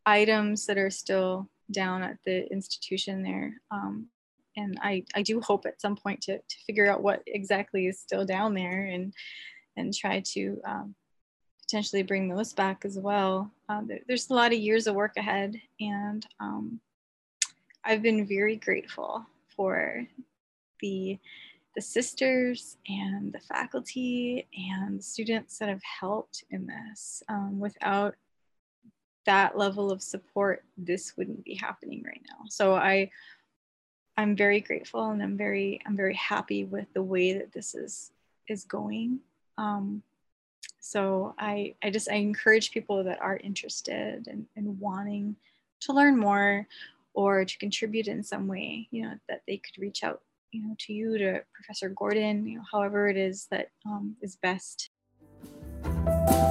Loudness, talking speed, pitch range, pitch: -30 LUFS, 155 wpm, 195-220 Hz, 205 Hz